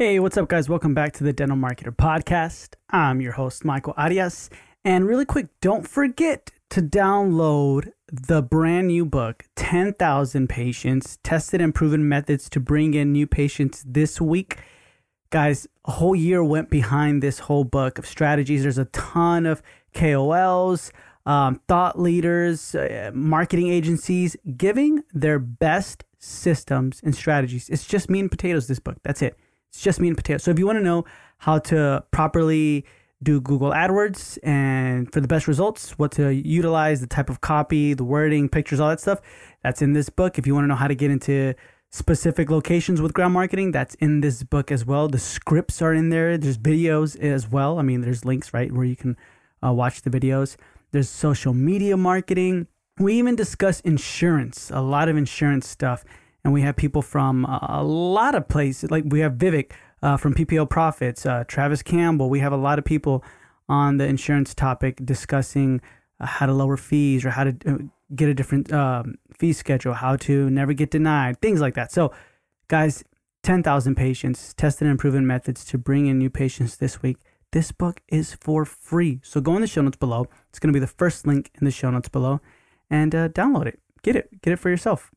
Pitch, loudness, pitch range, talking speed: 145 Hz, -22 LUFS, 135-165 Hz, 190 wpm